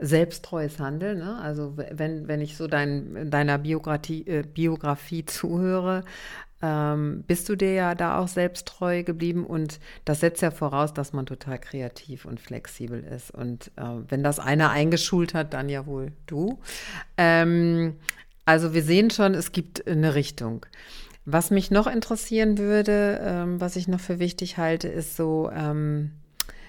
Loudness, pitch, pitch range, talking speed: -25 LUFS, 160 Hz, 150-180 Hz, 155 wpm